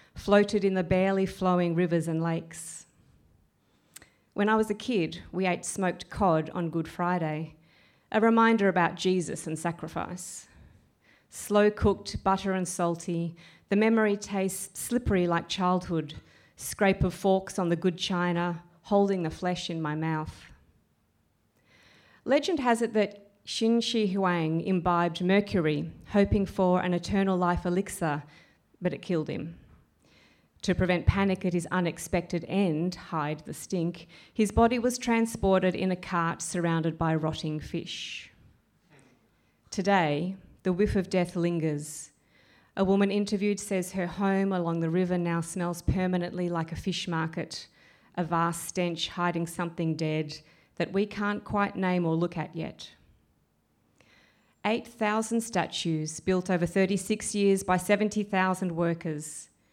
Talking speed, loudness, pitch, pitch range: 135 wpm, -28 LUFS, 180 Hz, 165-195 Hz